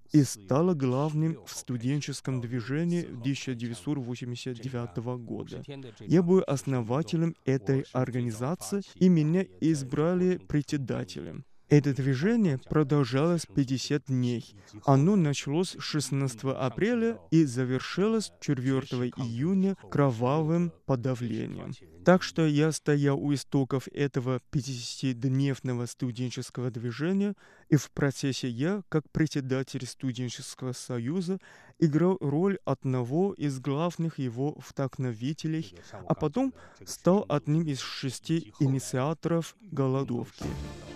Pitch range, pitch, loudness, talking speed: 130-160 Hz, 140 Hz, -29 LUFS, 95 wpm